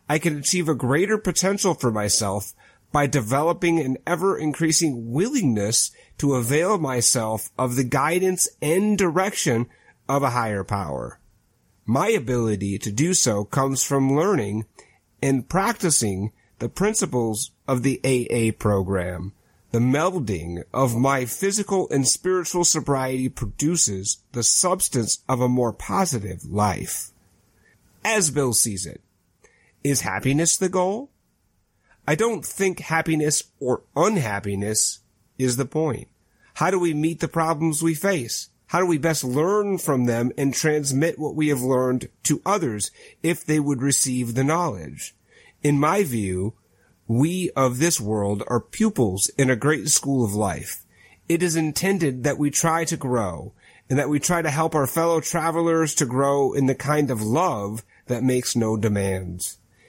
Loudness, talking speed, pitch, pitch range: -22 LUFS, 145 wpm, 135 Hz, 115-165 Hz